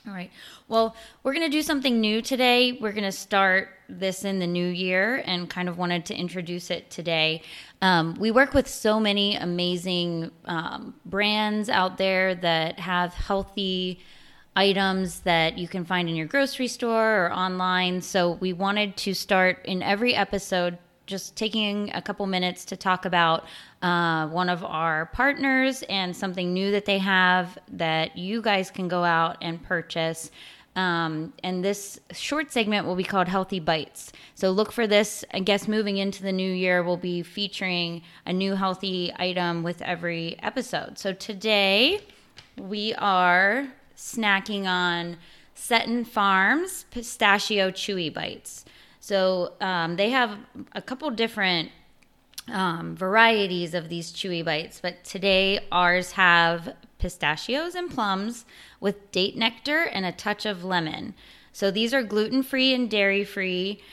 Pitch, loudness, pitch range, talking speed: 190 Hz, -24 LUFS, 180-215 Hz, 155 wpm